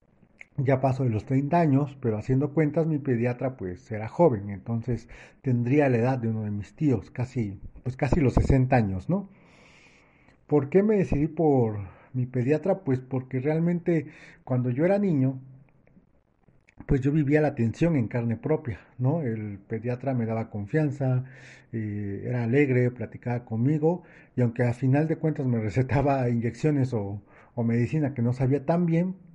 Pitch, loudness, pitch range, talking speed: 130 Hz, -26 LUFS, 115-150 Hz, 165 wpm